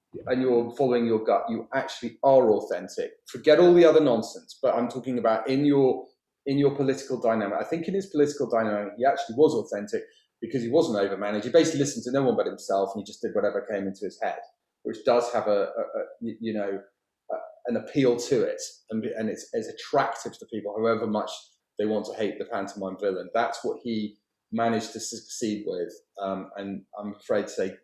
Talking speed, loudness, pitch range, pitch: 210 wpm, -26 LUFS, 105-145 Hz, 120 Hz